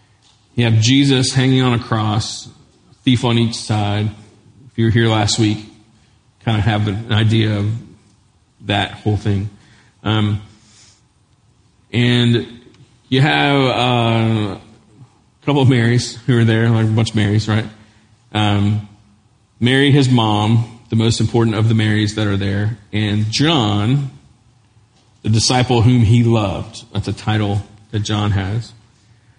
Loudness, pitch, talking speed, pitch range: -16 LUFS, 110 Hz, 145 wpm, 105-120 Hz